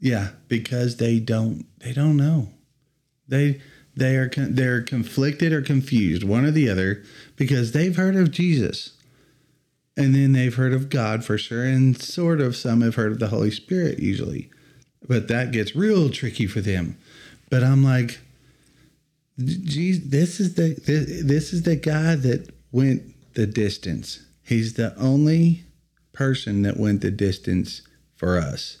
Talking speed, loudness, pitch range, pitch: 155 wpm, -22 LUFS, 115-150 Hz, 135 Hz